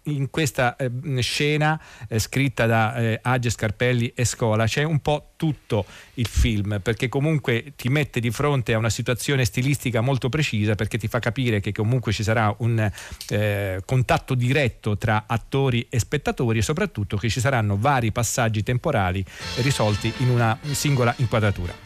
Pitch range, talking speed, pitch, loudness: 110-135 Hz, 165 wpm, 120 Hz, -23 LUFS